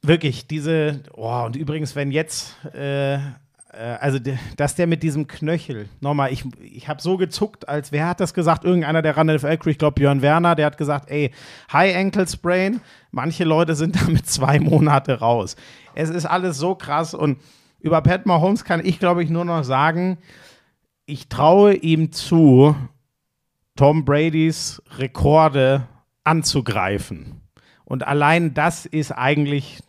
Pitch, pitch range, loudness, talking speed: 150 Hz, 140-165 Hz, -19 LUFS, 155 wpm